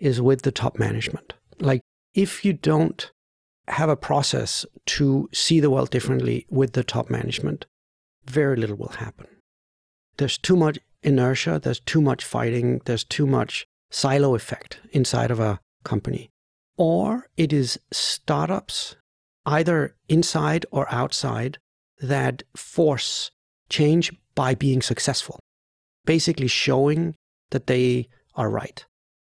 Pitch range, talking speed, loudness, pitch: 115-150 Hz, 125 wpm, -23 LUFS, 135 Hz